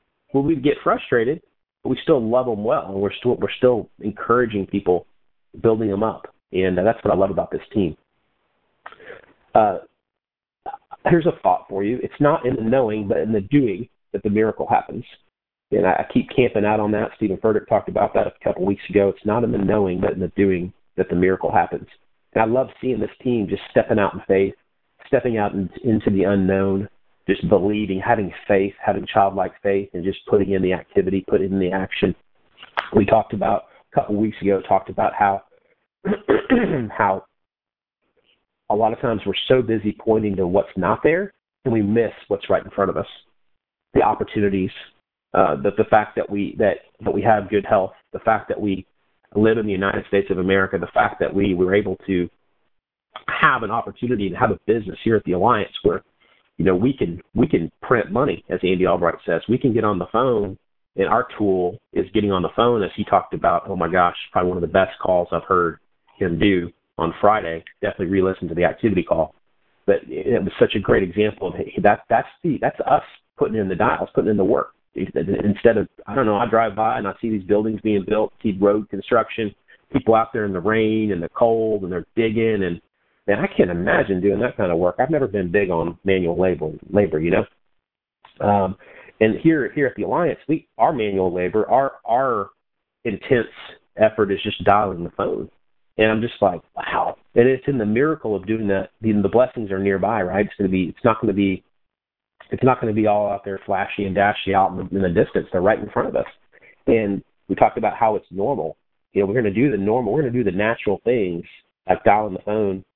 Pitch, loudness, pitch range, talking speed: 100 Hz, -20 LUFS, 95-110 Hz, 215 wpm